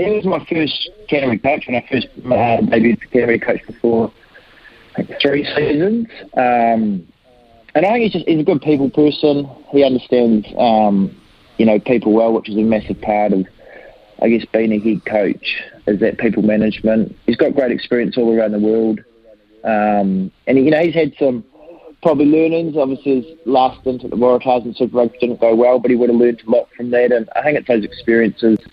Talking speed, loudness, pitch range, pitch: 200 wpm, -16 LUFS, 110-140 Hz, 120 Hz